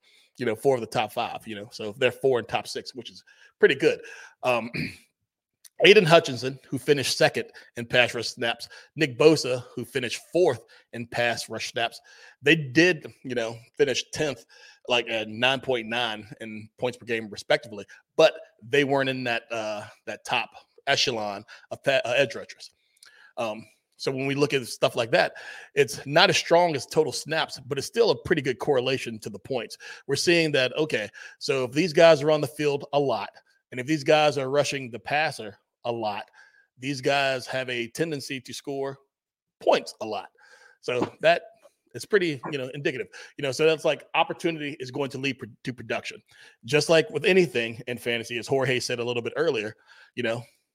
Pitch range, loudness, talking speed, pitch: 120-155 Hz, -25 LUFS, 190 wpm, 135 Hz